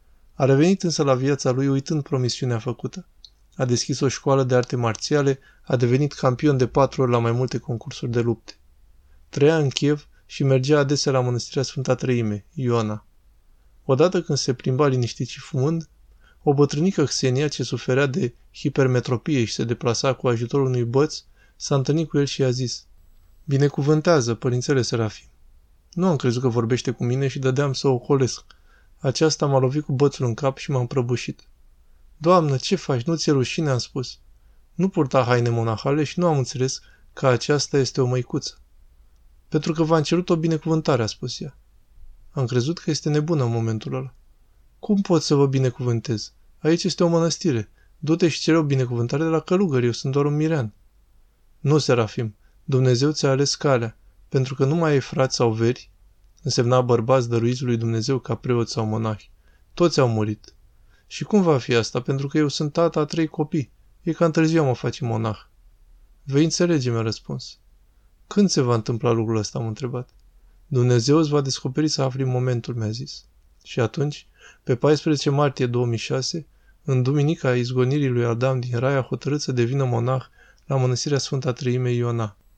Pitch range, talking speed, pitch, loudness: 115-145 Hz, 175 wpm, 130 Hz, -22 LUFS